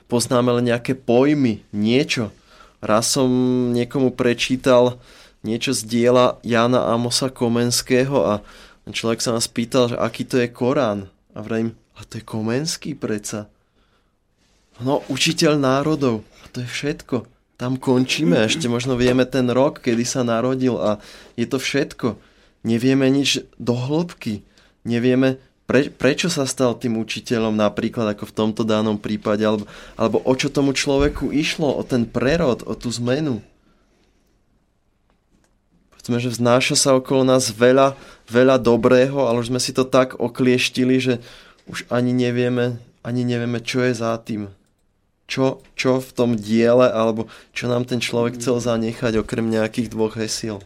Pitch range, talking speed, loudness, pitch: 115-130 Hz, 150 wpm, -20 LUFS, 120 Hz